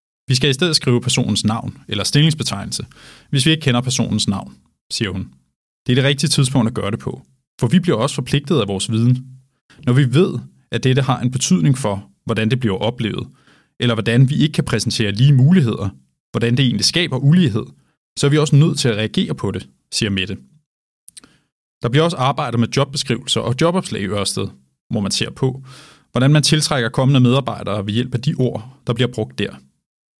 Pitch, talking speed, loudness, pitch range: 125 Hz, 200 wpm, -17 LUFS, 110-140 Hz